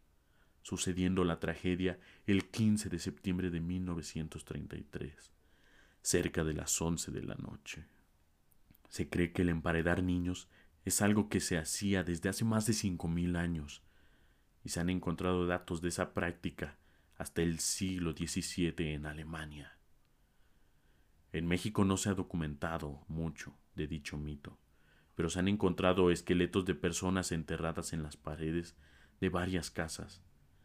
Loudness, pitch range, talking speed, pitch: -36 LUFS, 80-95 Hz, 140 wpm, 85 Hz